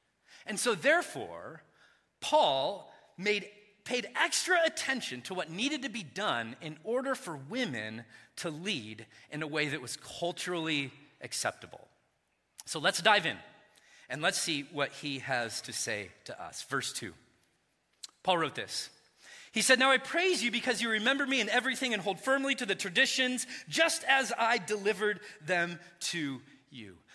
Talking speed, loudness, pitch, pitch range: 155 wpm, -31 LUFS, 210 Hz, 155-260 Hz